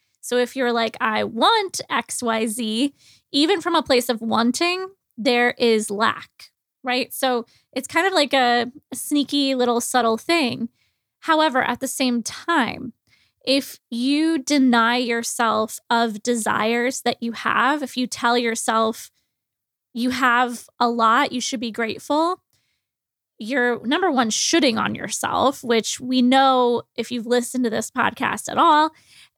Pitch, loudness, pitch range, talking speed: 250 Hz, -20 LUFS, 235-280 Hz, 145 wpm